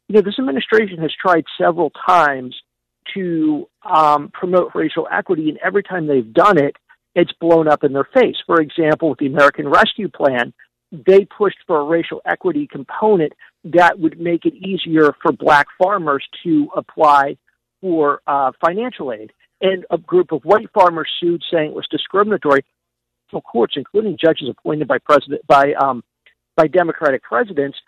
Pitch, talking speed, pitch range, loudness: 170 Hz, 165 wpm, 150-195 Hz, -16 LUFS